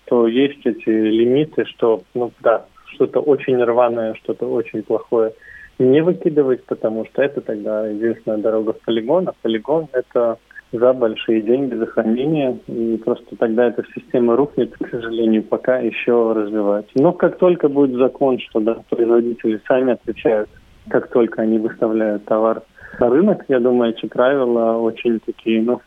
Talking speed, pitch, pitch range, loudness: 155 wpm, 115 Hz, 110-130 Hz, -18 LUFS